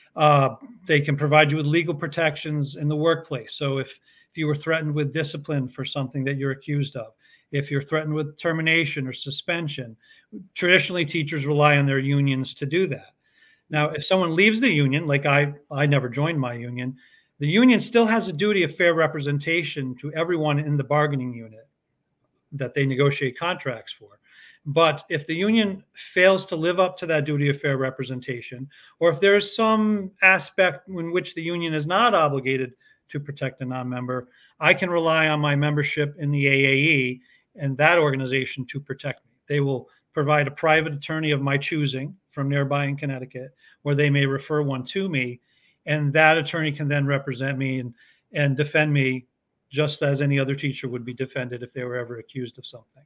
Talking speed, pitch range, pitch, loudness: 190 wpm, 135-160 Hz, 145 Hz, -22 LUFS